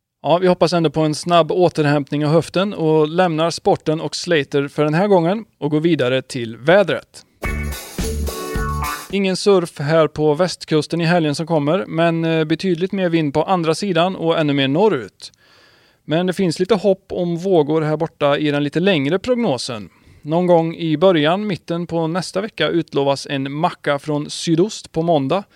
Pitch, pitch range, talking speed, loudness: 160 Hz, 150-180 Hz, 170 wpm, -18 LUFS